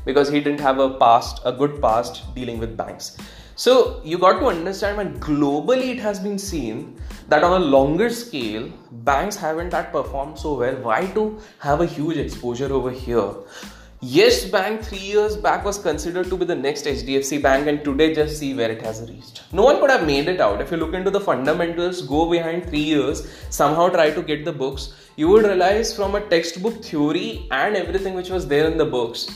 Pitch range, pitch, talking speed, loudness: 145-195 Hz, 165 Hz, 205 wpm, -20 LUFS